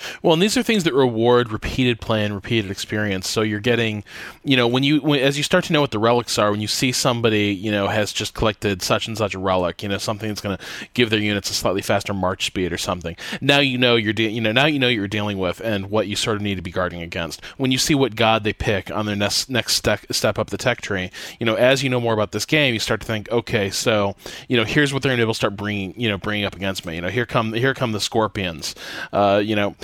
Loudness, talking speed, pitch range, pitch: -20 LUFS, 285 wpm, 100-125 Hz, 110 Hz